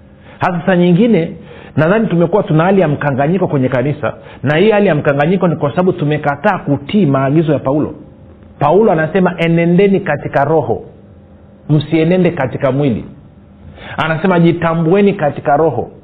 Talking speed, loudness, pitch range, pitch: 135 wpm, -13 LUFS, 135-180 Hz, 155 Hz